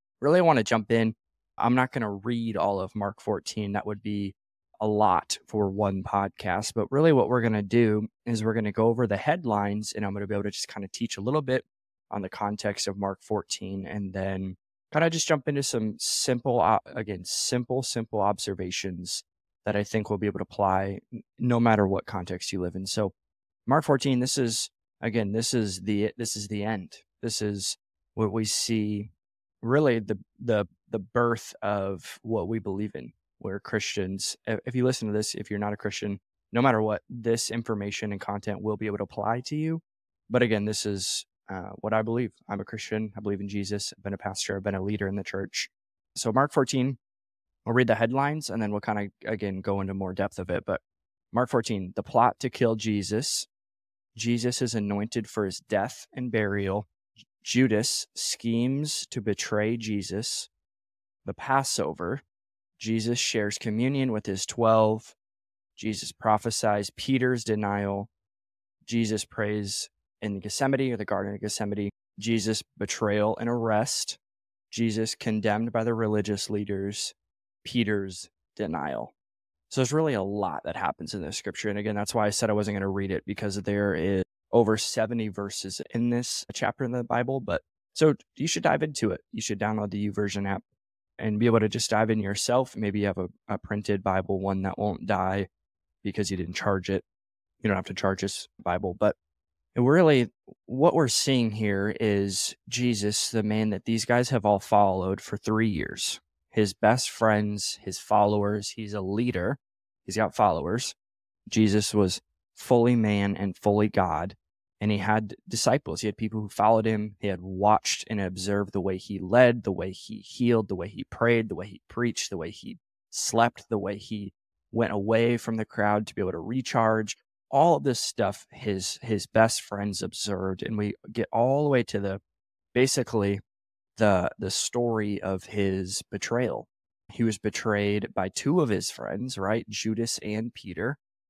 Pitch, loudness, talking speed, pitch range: 105 Hz, -27 LUFS, 185 wpm, 100-115 Hz